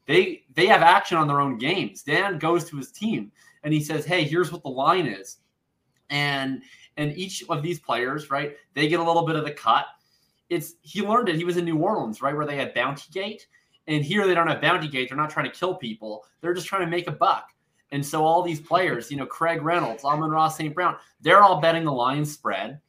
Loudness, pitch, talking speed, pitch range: -23 LUFS, 160 Hz, 240 wpm, 145-175 Hz